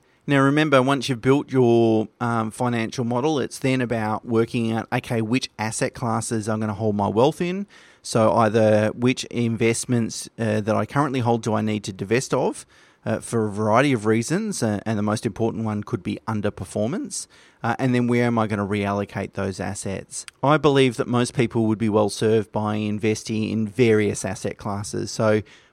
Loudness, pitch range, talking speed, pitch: -22 LUFS, 105-125 Hz, 190 wpm, 115 Hz